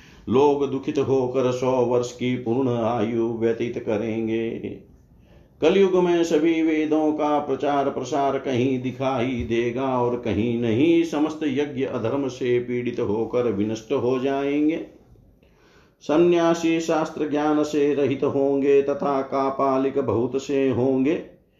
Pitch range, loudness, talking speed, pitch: 120-145 Hz, -22 LUFS, 120 wpm, 135 Hz